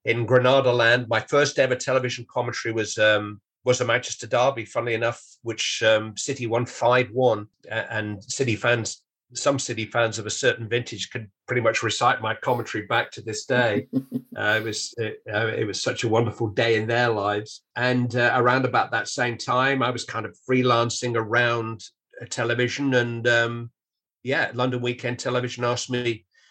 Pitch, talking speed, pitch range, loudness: 120 Hz, 175 wpm, 115-125 Hz, -23 LUFS